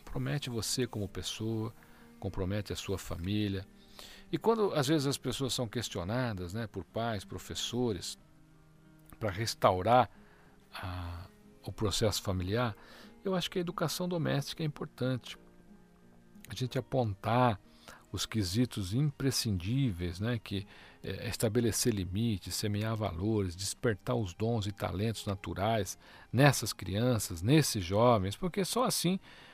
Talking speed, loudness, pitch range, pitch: 120 wpm, -33 LUFS, 100-130 Hz, 110 Hz